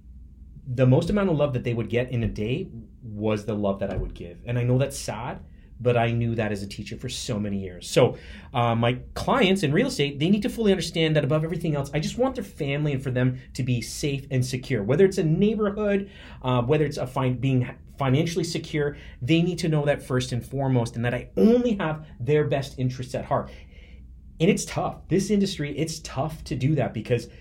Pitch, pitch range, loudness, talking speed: 130 Hz, 115-160 Hz, -25 LUFS, 230 wpm